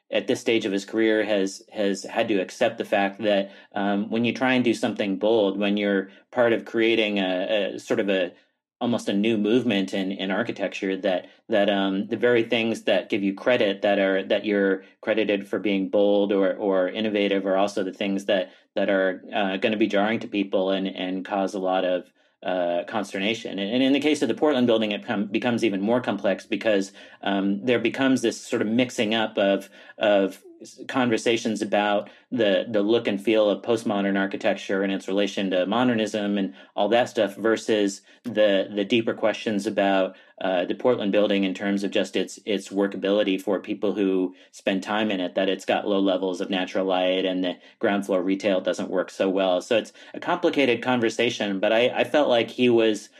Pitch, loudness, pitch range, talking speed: 100 Hz, -24 LUFS, 95-110 Hz, 205 wpm